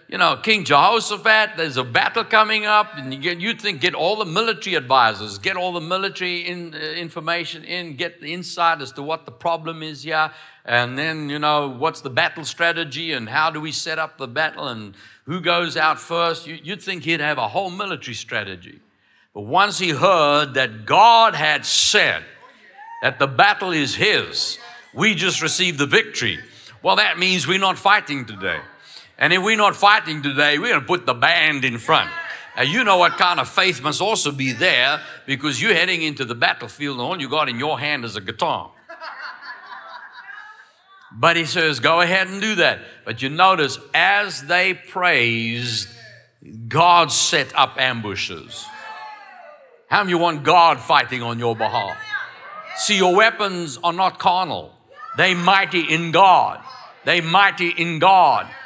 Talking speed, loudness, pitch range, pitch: 175 wpm, -18 LUFS, 150-190 Hz, 170 Hz